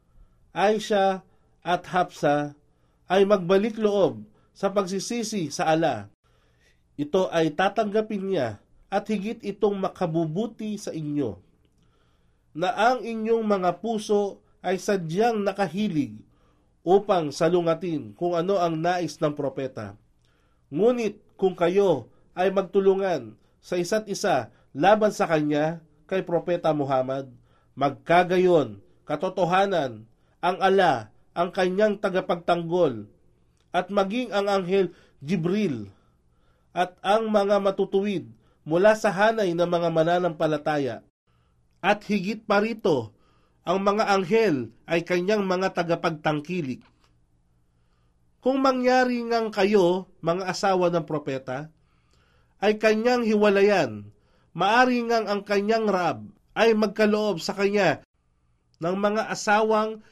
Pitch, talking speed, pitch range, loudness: 180 Hz, 105 wpm, 145-205 Hz, -24 LUFS